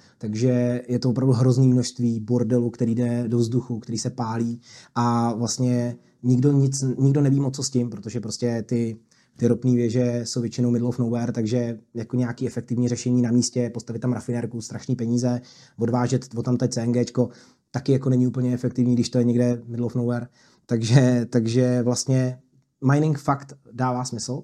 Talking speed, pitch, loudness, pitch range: 175 wpm, 120 Hz, -23 LUFS, 120-125 Hz